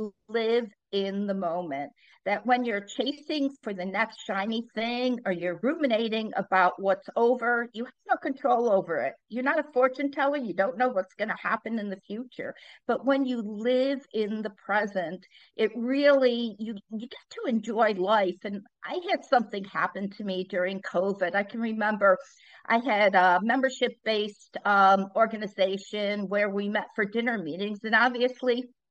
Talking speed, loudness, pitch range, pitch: 170 wpm, -27 LUFS, 195-250 Hz, 220 Hz